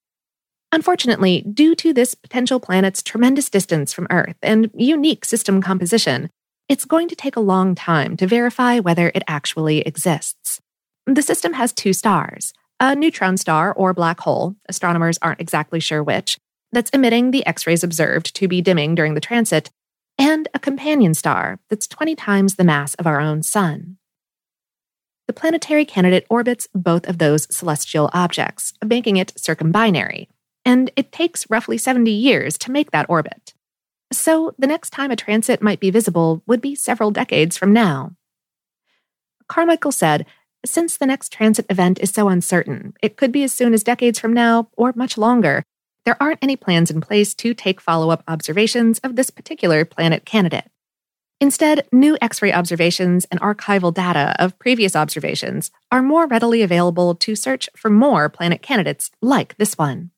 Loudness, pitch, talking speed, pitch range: -17 LUFS, 205 Hz, 165 wpm, 175-250 Hz